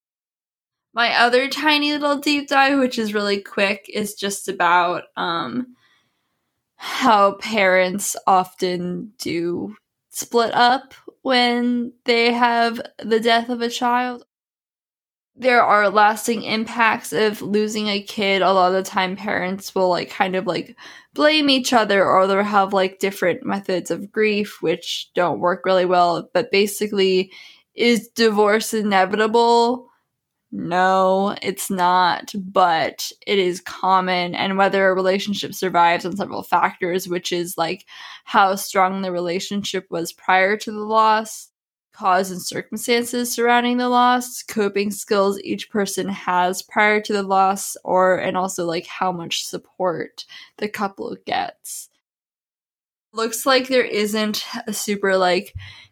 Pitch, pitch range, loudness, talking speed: 205 Hz, 185-235 Hz, -19 LUFS, 135 wpm